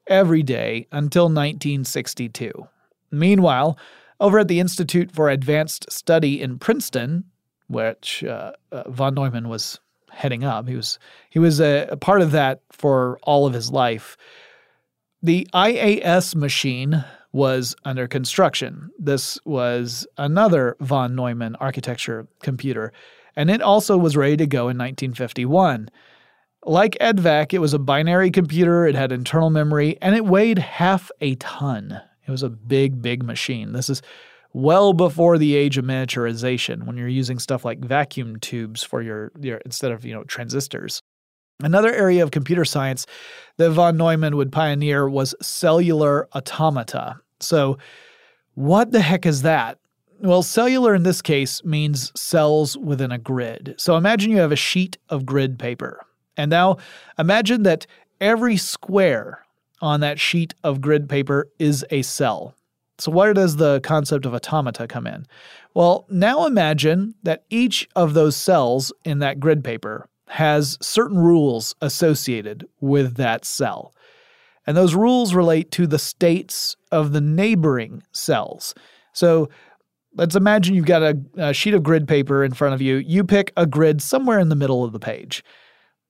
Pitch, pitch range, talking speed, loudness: 150 Hz, 130-175 Hz, 155 wpm, -19 LUFS